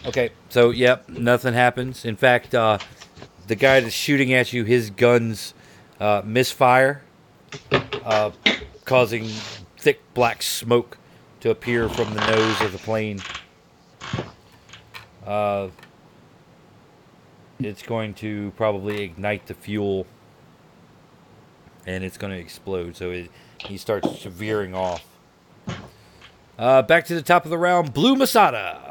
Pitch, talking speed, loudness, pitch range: 110 Hz, 125 wpm, -21 LUFS, 100-125 Hz